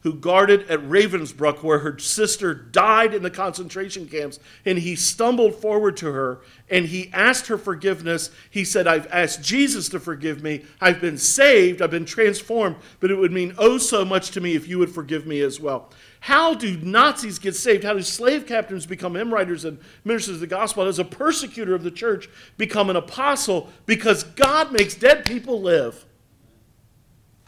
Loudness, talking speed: -20 LUFS, 190 wpm